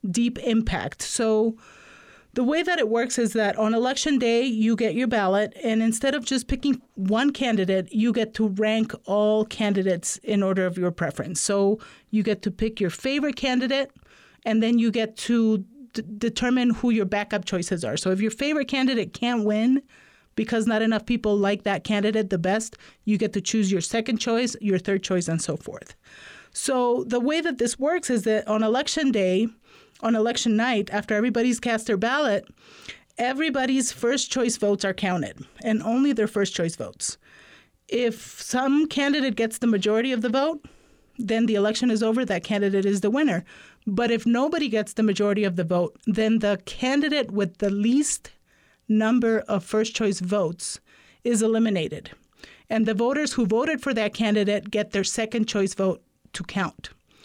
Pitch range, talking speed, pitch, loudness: 205-245 Hz, 180 wpm, 225 Hz, -24 LUFS